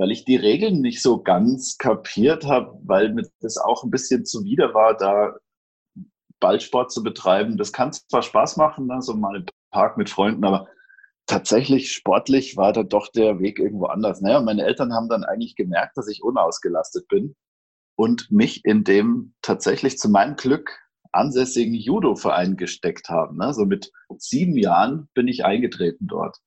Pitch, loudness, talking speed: 135 Hz, -21 LUFS, 170 wpm